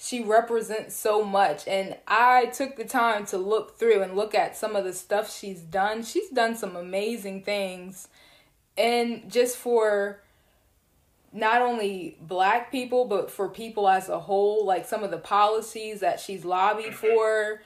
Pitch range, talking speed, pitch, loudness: 195-225 Hz, 165 wpm, 215 Hz, -25 LUFS